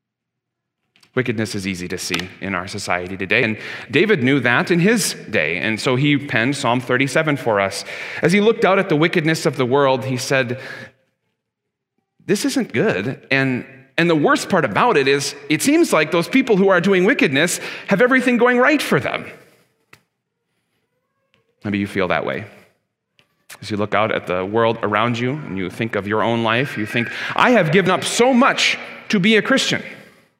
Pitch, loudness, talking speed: 135 Hz, -18 LUFS, 190 wpm